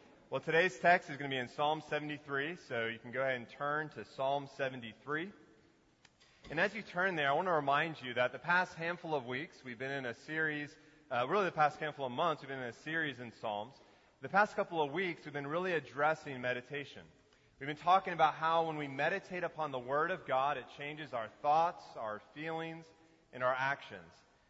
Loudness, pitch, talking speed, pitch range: -36 LUFS, 150 Hz, 215 wpm, 130-160 Hz